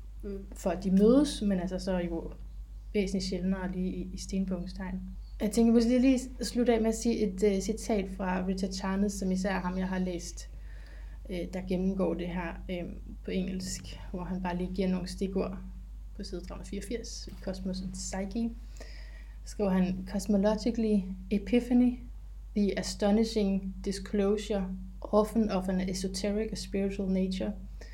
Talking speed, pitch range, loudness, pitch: 155 wpm, 185-210 Hz, -31 LUFS, 195 Hz